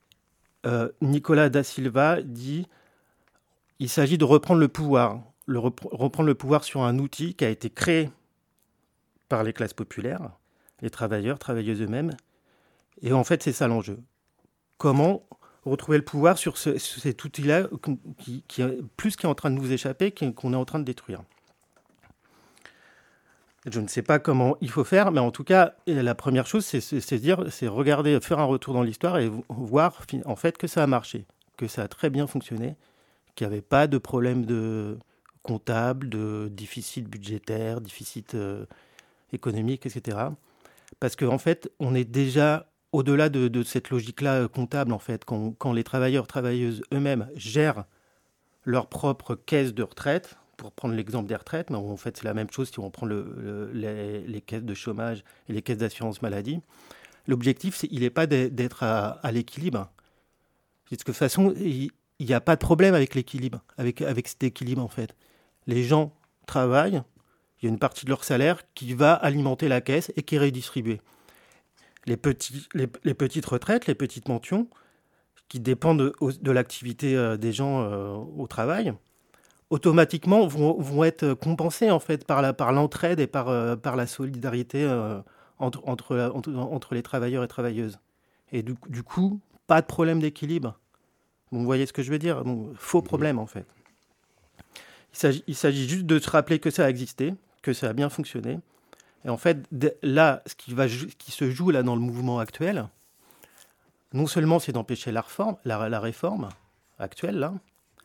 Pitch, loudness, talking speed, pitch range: 130 Hz, -26 LUFS, 175 wpm, 120-150 Hz